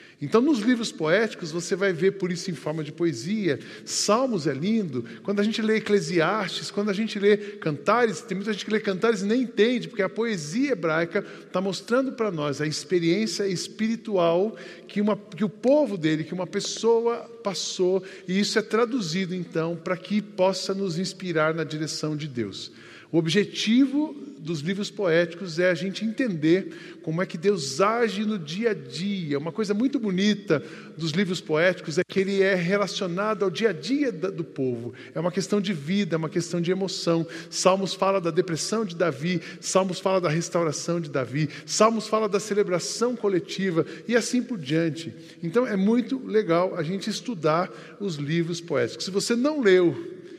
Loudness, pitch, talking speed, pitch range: -25 LUFS, 190 Hz, 180 wpm, 170-215 Hz